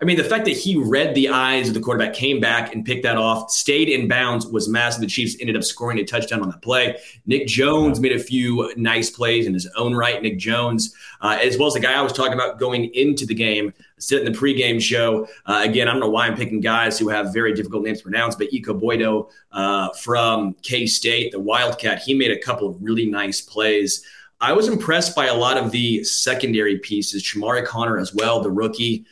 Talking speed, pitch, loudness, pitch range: 235 wpm, 115 Hz, -19 LUFS, 110-125 Hz